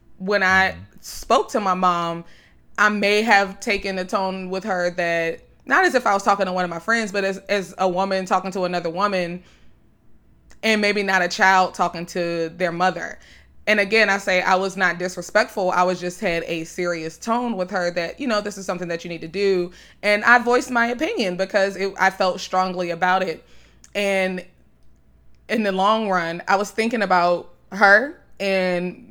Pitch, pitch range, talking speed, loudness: 190 Hz, 180-205 Hz, 195 wpm, -20 LUFS